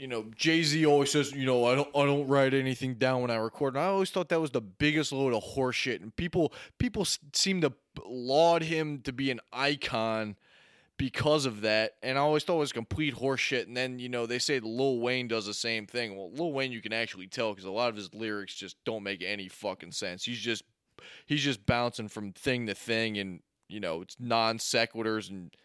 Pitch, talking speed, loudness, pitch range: 125 Hz, 225 wpm, -30 LUFS, 110-140 Hz